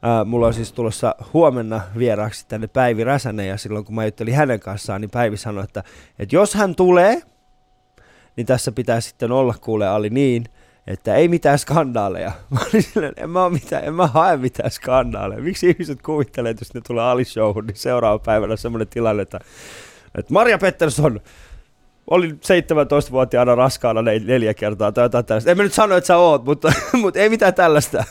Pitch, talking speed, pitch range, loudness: 125 Hz, 170 wpm, 110-150 Hz, -18 LUFS